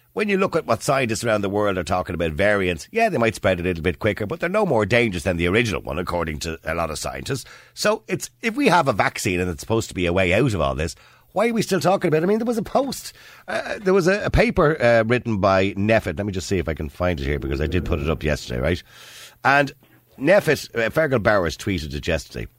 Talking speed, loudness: 275 wpm, -21 LUFS